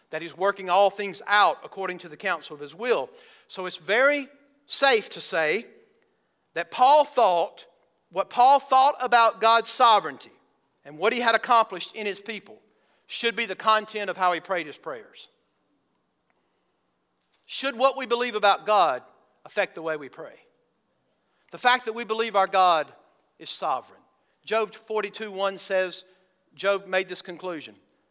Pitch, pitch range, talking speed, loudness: 215 Hz, 185-250 Hz, 160 wpm, -24 LUFS